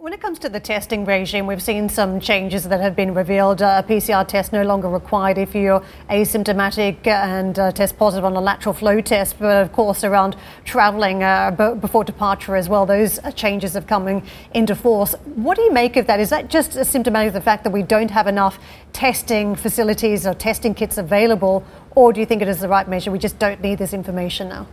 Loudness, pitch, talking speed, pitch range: -18 LUFS, 205 Hz, 220 wpm, 195-220 Hz